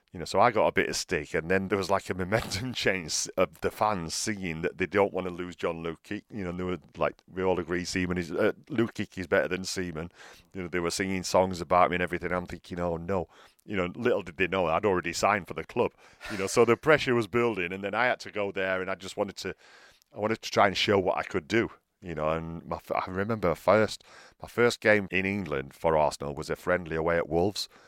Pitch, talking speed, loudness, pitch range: 95 Hz, 260 wpm, -28 LUFS, 90-100 Hz